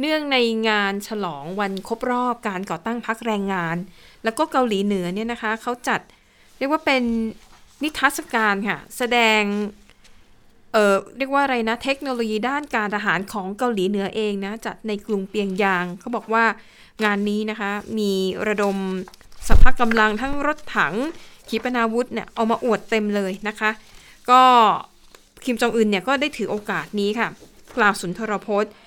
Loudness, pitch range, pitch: -22 LUFS, 205-240 Hz, 220 Hz